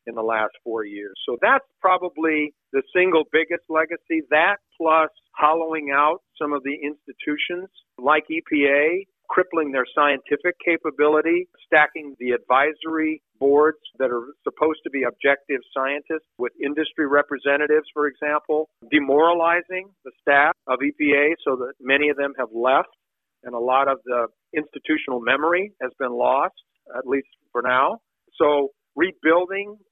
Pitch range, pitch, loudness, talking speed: 135-160 Hz, 150 Hz, -21 LUFS, 140 wpm